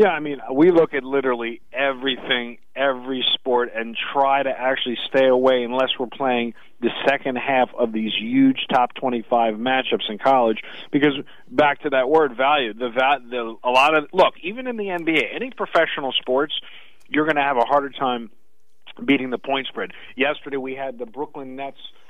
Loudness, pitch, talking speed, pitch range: -21 LUFS, 135 Hz, 180 wpm, 125-145 Hz